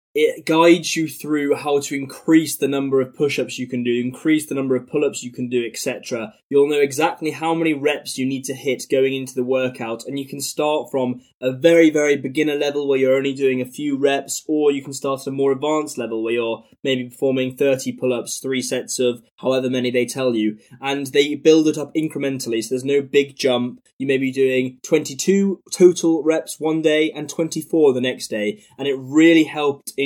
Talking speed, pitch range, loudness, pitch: 220 wpm, 130-150 Hz, -20 LUFS, 140 Hz